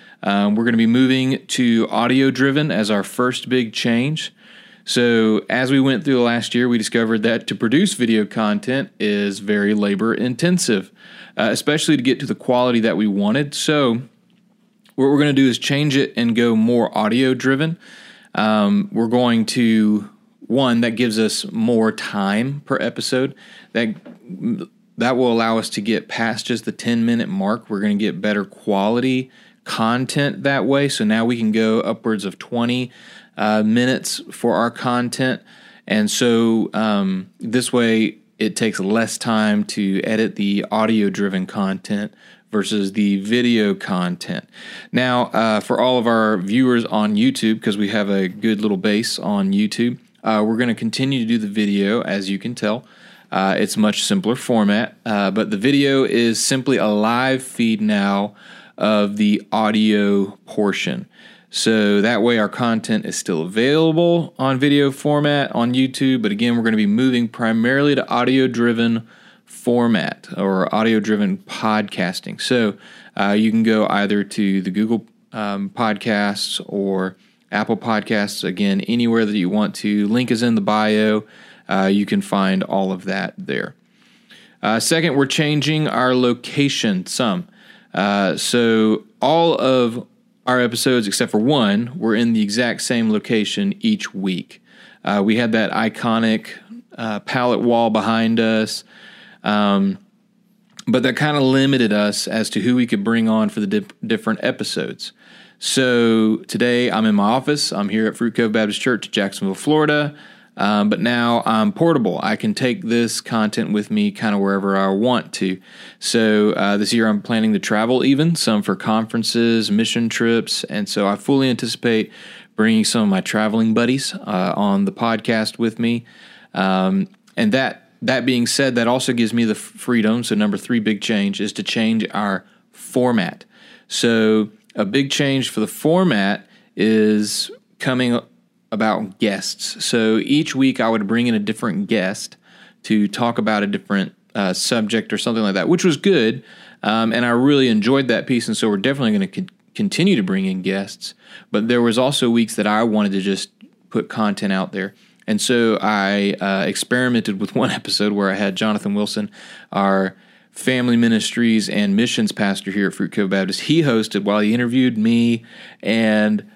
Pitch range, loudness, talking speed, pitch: 105-135 Hz, -18 LUFS, 170 wpm, 115 Hz